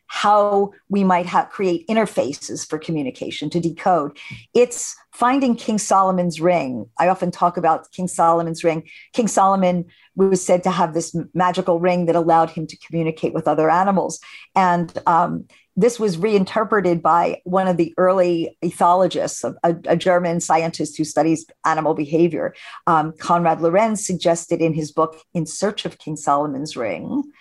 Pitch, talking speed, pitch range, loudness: 175 Hz, 155 wpm, 165-195 Hz, -19 LUFS